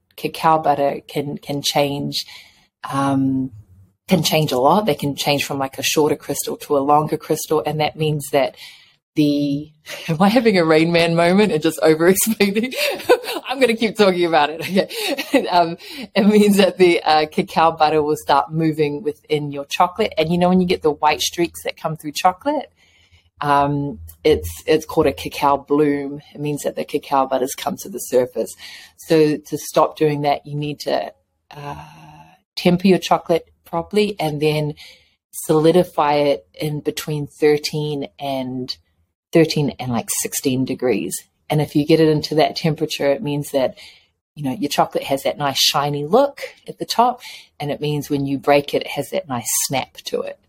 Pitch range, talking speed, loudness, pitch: 145-170 Hz, 180 wpm, -19 LUFS, 150 Hz